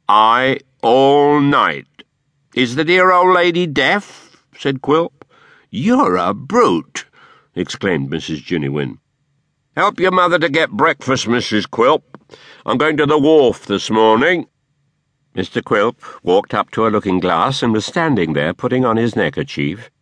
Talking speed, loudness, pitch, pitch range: 140 wpm, -15 LUFS, 140 Hz, 115-160 Hz